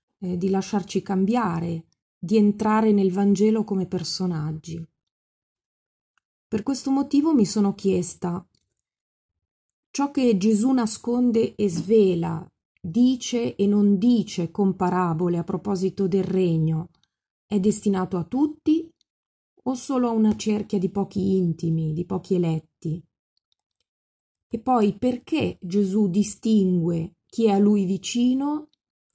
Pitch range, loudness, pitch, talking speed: 180-225 Hz, -23 LUFS, 200 Hz, 115 wpm